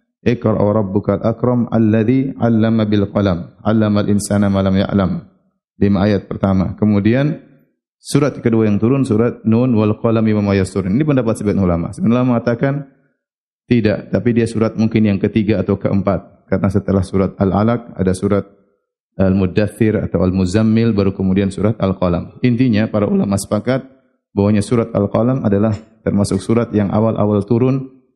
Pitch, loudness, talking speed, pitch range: 105 Hz, -16 LUFS, 160 wpm, 100-115 Hz